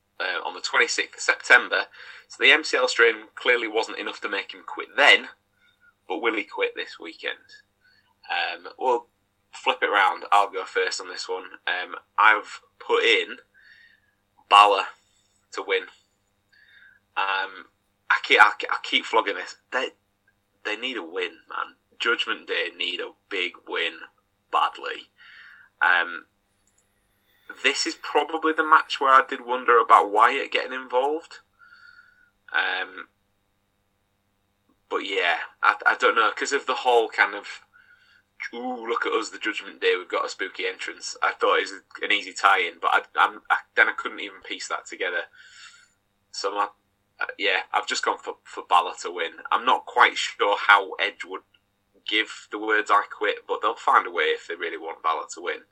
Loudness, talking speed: -23 LUFS, 165 wpm